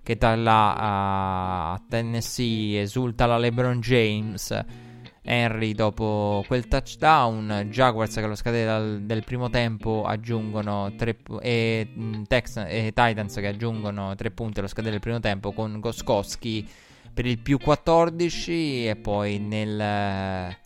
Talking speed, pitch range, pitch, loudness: 135 wpm, 105-120 Hz, 110 Hz, -25 LUFS